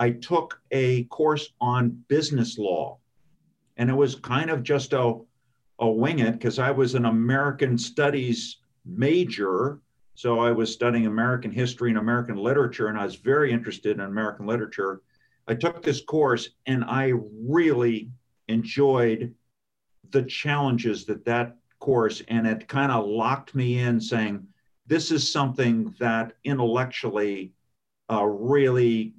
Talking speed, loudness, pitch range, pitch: 140 wpm, -25 LUFS, 115-135 Hz, 120 Hz